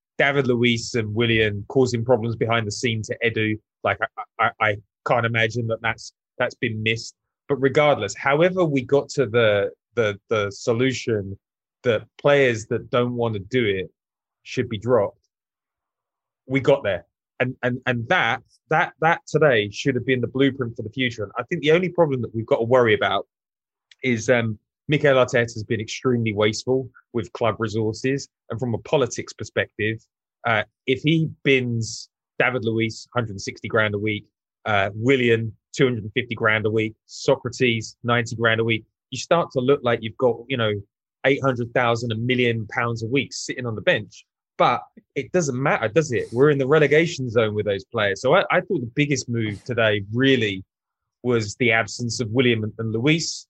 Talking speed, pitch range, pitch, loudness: 180 wpm, 110-130 Hz, 120 Hz, -22 LUFS